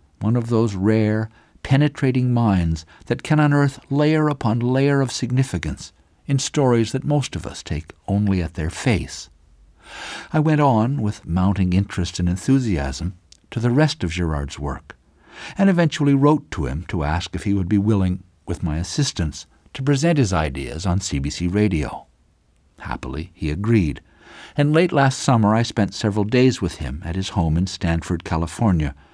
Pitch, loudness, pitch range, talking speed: 100 Hz, -21 LUFS, 85-130 Hz, 165 wpm